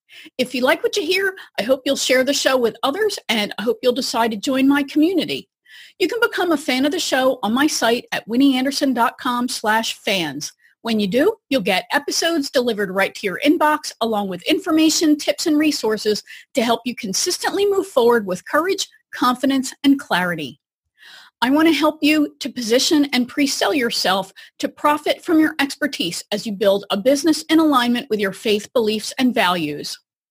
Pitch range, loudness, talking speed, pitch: 225-310 Hz, -19 LUFS, 185 wpm, 270 Hz